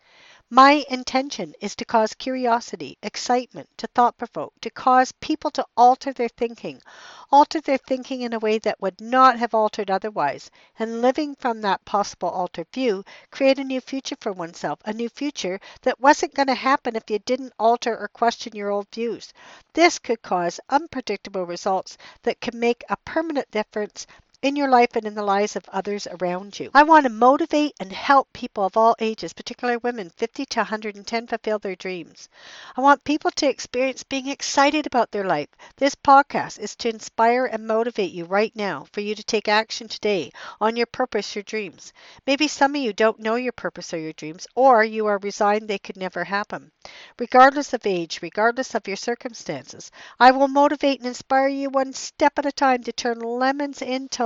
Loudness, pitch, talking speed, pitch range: -22 LUFS, 235 Hz, 190 wpm, 210-265 Hz